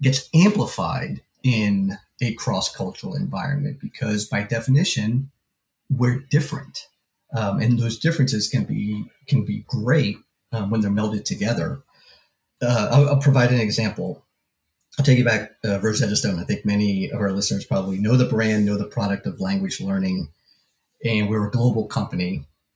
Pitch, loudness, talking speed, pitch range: 115 Hz, -22 LUFS, 155 wpm, 105-135 Hz